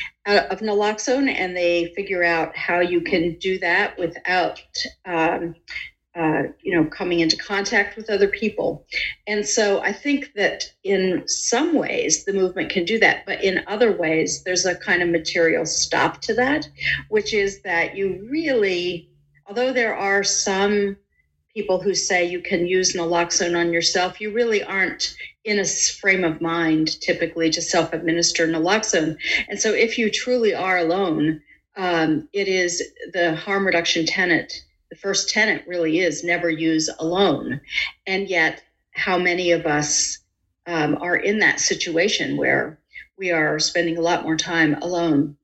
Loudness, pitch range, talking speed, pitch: -20 LUFS, 165-200 Hz, 155 wpm, 180 Hz